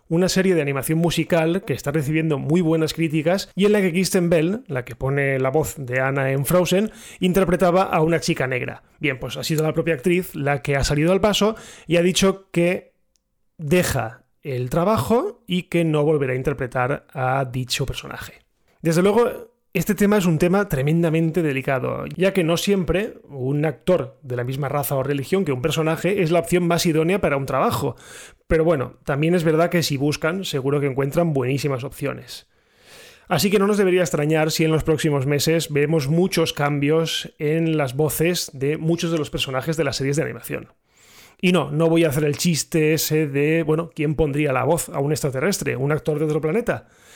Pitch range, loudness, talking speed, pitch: 145-175 Hz, -21 LUFS, 195 wpm, 160 Hz